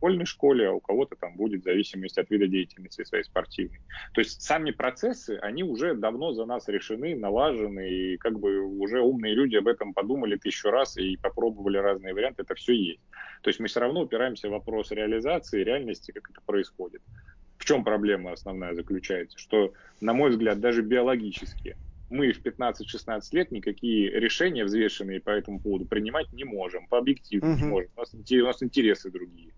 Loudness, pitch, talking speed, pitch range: -27 LUFS, 105 Hz, 175 wpm, 95-125 Hz